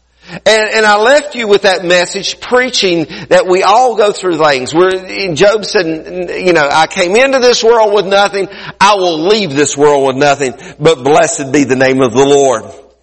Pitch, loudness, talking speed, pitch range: 180 Hz, -10 LUFS, 195 wpm, 155-210 Hz